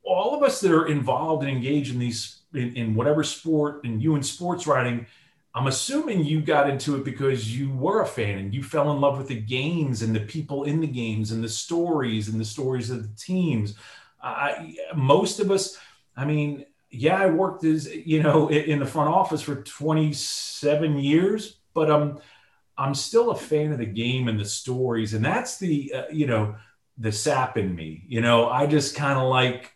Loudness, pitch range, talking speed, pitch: -24 LUFS, 120-155 Hz, 210 wpm, 140 Hz